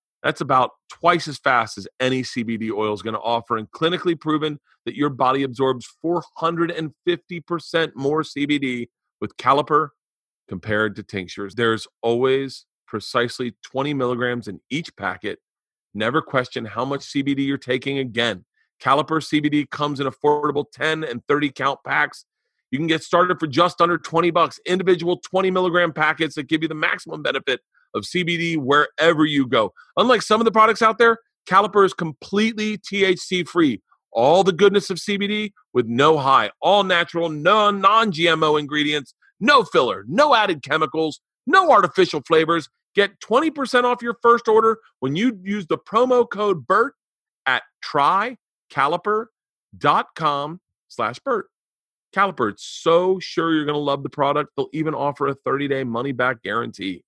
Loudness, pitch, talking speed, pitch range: -20 LUFS, 155 Hz, 150 wpm, 135-185 Hz